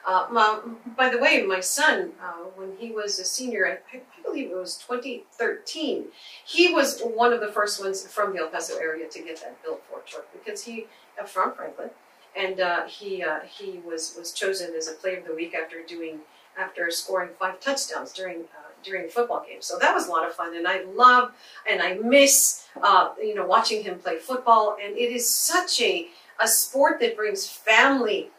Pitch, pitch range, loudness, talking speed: 225 Hz, 185-280 Hz, -23 LUFS, 205 wpm